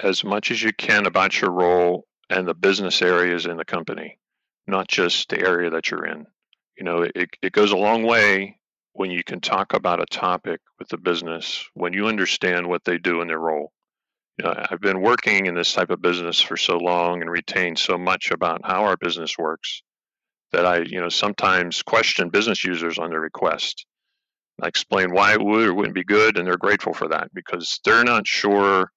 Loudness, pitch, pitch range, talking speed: -20 LUFS, 90 Hz, 85-95 Hz, 205 wpm